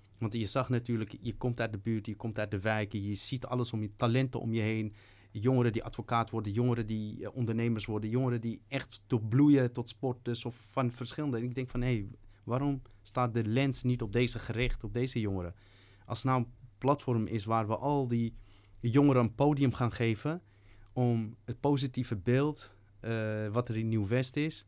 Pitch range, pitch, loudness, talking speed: 110-125 Hz, 115 Hz, -33 LUFS, 210 wpm